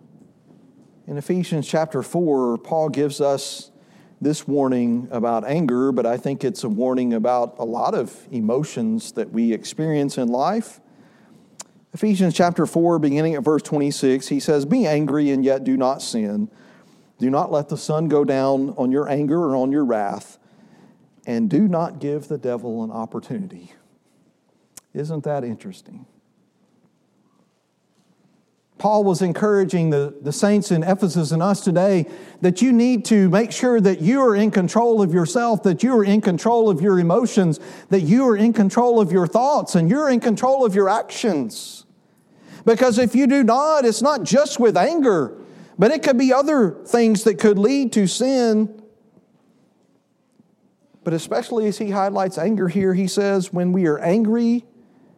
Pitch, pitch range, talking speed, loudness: 190 Hz, 150-225 Hz, 160 wpm, -19 LUFS